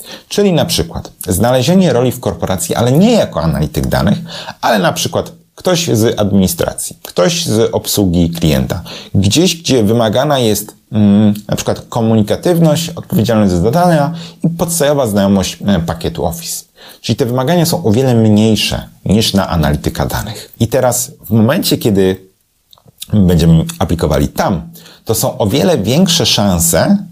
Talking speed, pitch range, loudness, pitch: 140 wpm, 95-150 Hz, -13 LUFS, 110 Hz